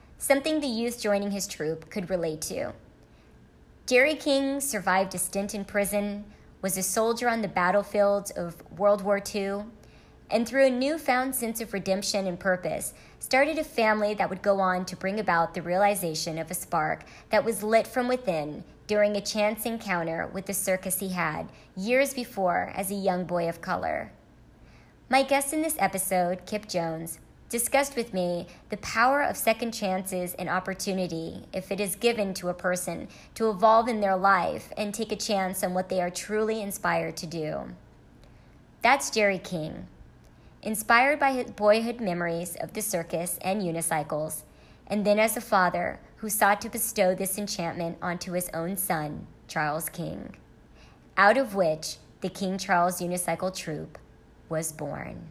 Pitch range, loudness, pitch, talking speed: 175-220 Hz, -27 LUFS, 195 Hz, 165 wpm